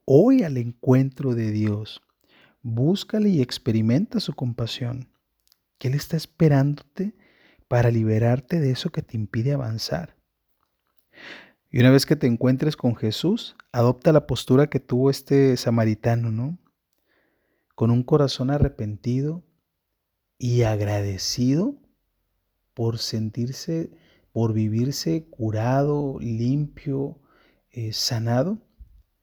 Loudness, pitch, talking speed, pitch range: -23 LUFS, 125 Hz, 105 wpm, 115-145 Hz